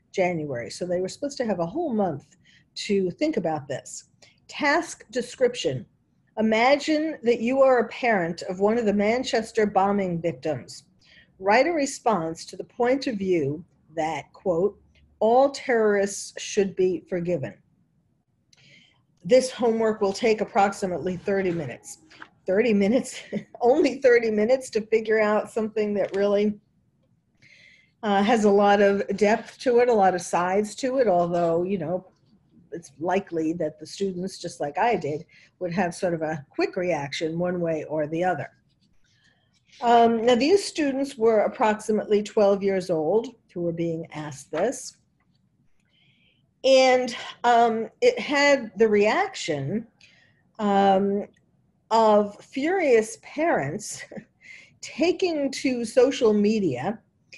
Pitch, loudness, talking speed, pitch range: 205 Hz, -24 LUFS, 135 wpm, 180-245 Hz